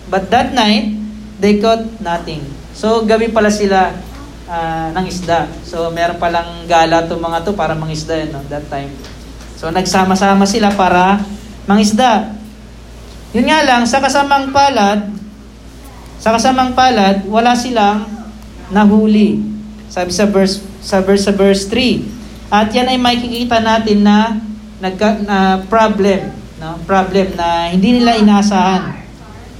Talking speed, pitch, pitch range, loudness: 140 wpm, 200 Hz, 180-220 Hz, -13 LUFS